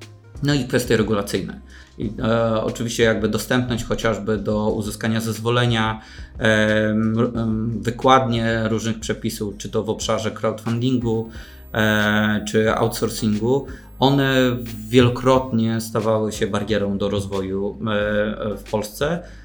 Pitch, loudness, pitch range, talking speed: 110 Hz, -21 LUFS, 105-115 Hz, 110 wpm